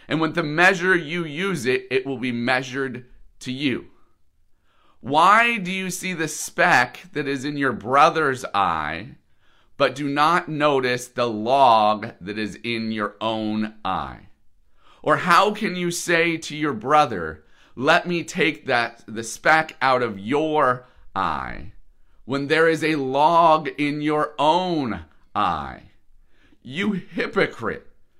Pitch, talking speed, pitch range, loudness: 145 Hz, 140 wpm, 120-165 Hz, -21 LUFS